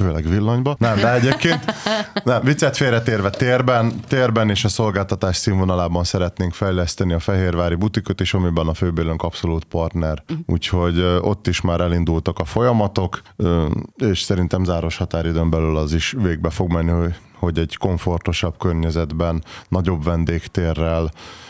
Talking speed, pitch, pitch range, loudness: 135 wpm, 90 Hz, 85-110 Hz, -19 LUFS